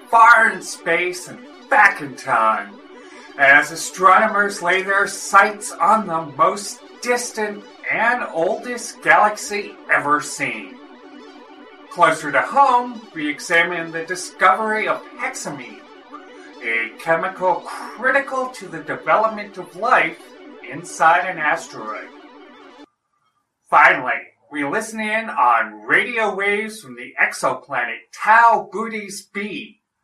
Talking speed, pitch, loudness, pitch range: 110 wpm, 205 Hz, -18 LUFS, 175-225 Hz